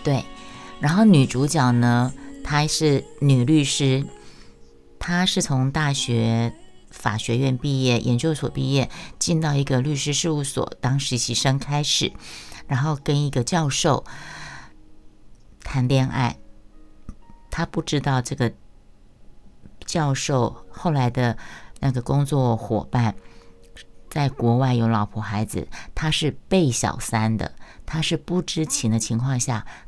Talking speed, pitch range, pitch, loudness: 185 characters per minute, 120-145 Hz, 135 Hz, -22 LUFS